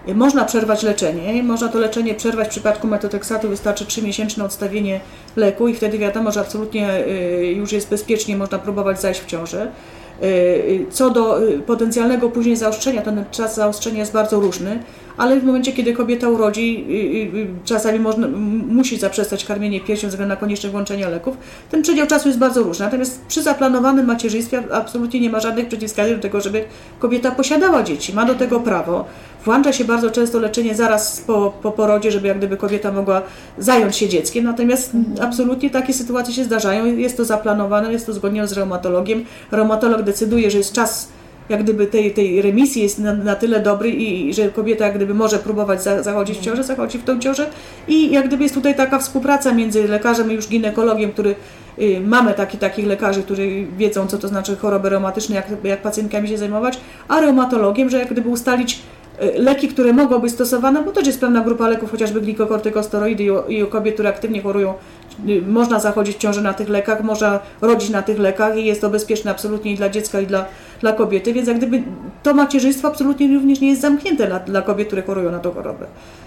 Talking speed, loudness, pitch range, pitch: 190 wpm, -18 LUFS, 205-240 Hz, 220 Hz